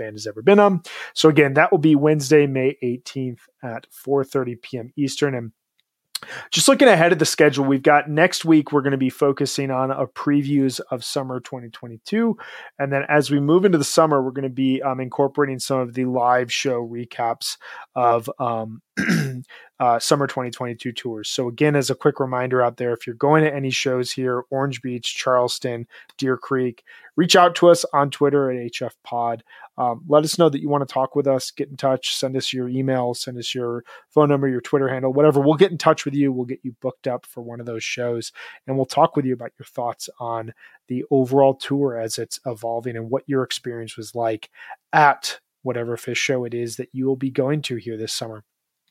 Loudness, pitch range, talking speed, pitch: -20 LUFS, 120-145 Hz, 210 wpm, 130 Hz